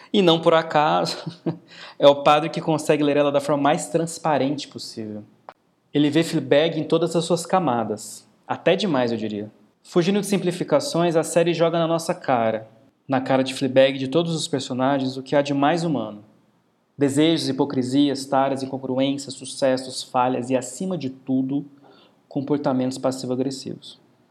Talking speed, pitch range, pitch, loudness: 155 wpm, 130-160 Hz, 140 Hz, -22 LUFS